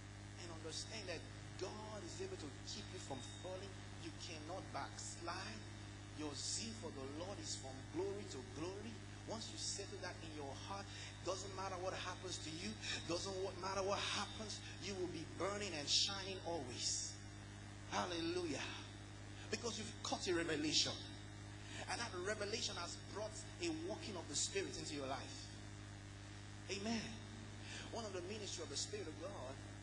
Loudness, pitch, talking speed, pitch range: -45 LUFS, 105 Hz, 155 wpm, 100-105 Hz